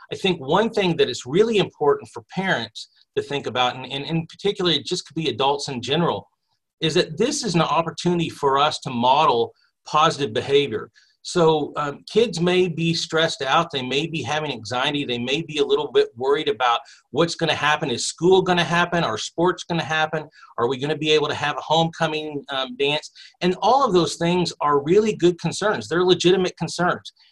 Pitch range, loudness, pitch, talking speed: 150-185 Hz, -21 LUFS, 165 Hz, 200 wpm